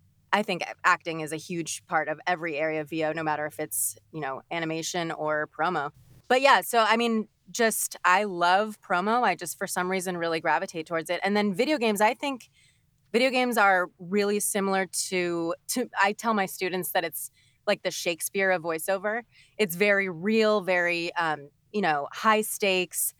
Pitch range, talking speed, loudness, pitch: 160-205 Hz, 185 wpm, -26 LUFS, 180 Hz